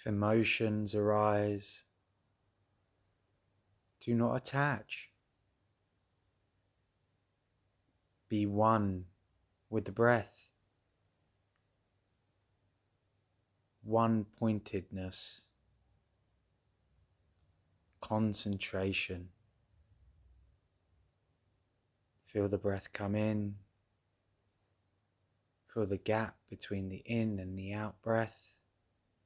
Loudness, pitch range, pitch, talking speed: -35 LUFS, 95-110 Hz, 100 Hz, 60 wpm